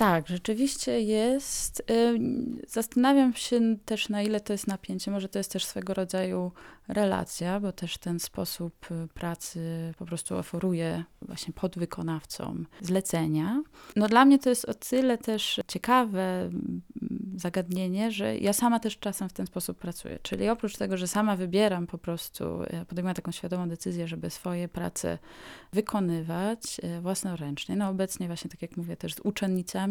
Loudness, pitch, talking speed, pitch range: -29 LUFS, 190 Hz, 150 wpm, 175-220 Hz